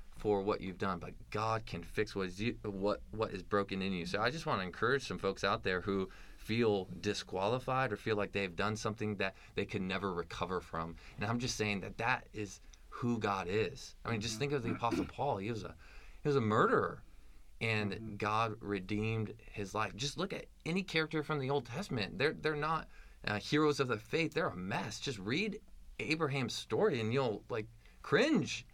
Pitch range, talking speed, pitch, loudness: 100-125 Hz, 210 wpm, 105 Hz, -36 LUFS